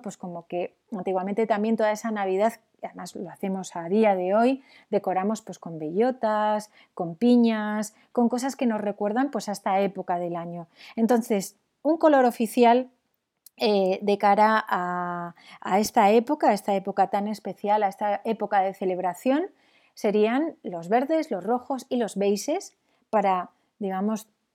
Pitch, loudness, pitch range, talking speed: 215 Hz, -25 LUFS, 195-240 Hz, 155 wpm